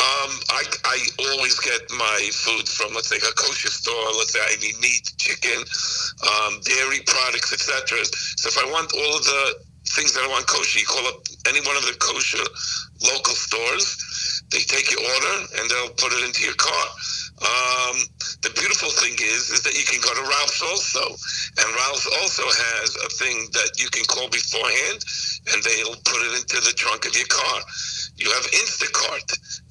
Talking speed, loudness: 190 wpm, -20 LUFS